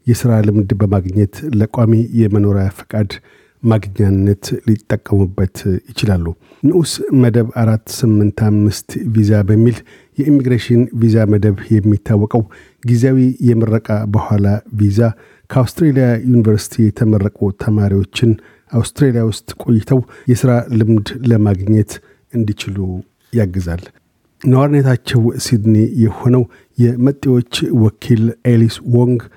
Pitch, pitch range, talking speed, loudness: 115 Hz, 105-120 Hz, 90 wpm, -14 LUFS